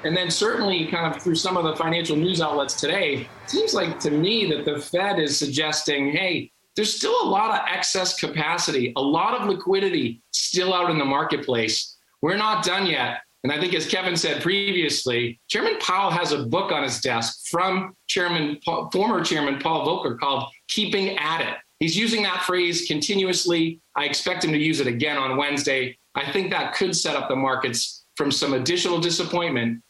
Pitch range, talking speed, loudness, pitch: 140-185 Hz, 195 wpm, -23 LUFS, 165 Hz